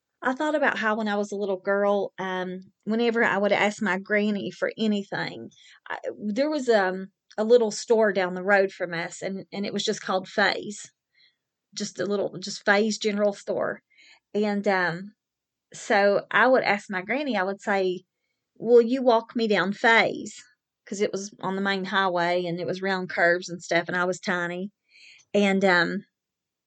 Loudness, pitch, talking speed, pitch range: -24 LUFS, 200 Hz, 185 wpm, 185-215 Hz